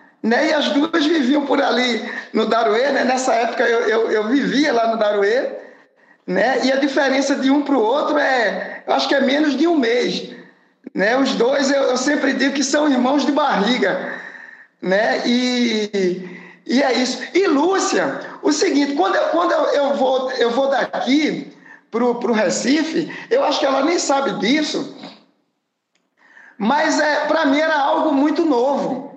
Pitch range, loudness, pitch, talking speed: 250-300 Hz, -17 LUFS, 275 Hz, 175 wpm